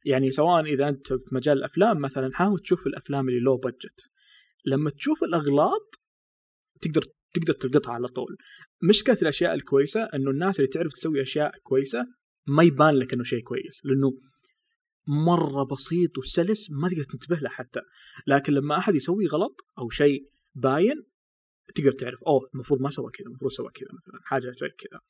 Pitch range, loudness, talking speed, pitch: 135-175 Hz, -25 LUFS, 165 wpm, 145 Hz